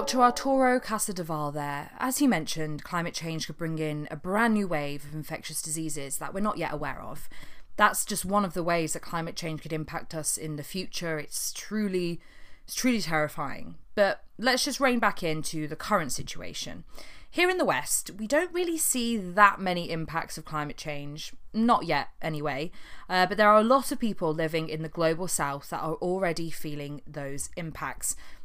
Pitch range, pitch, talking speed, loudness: 155-210 Hz, 165 Hz, 190 wpm, -28 LUFS